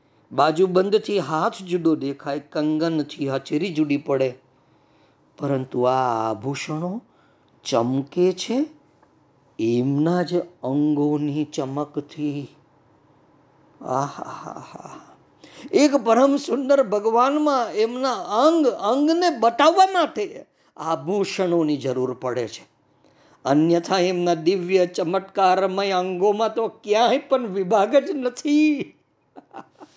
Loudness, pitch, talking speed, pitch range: -21 LUFS, 180 Hz, 75 wpm, 145-230 Hz